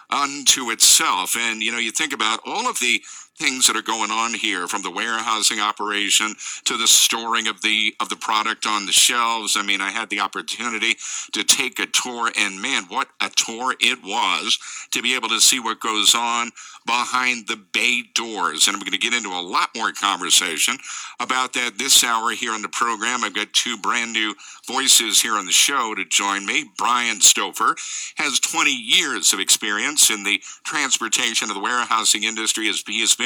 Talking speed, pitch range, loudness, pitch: 195 wpm, 110-120 Hz, -18 LUFS, 115 Hz